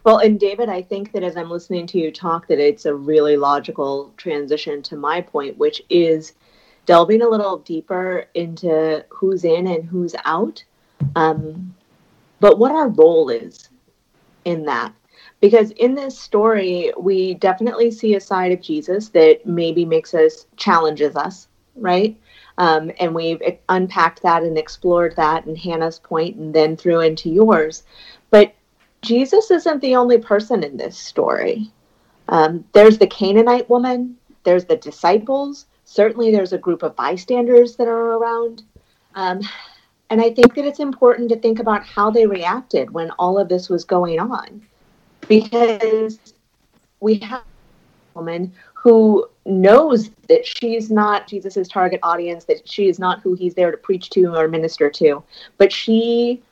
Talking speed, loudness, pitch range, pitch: 160 wpm, -17 LUFS, 170-230 Hz, 195 Hz